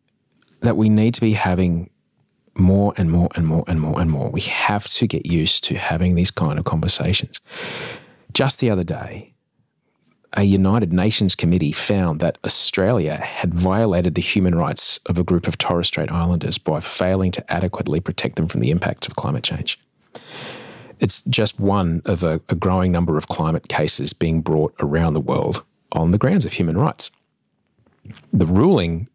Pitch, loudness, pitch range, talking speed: 90 Hz, -19 LUFS, 85-100 Hz, 175 wpm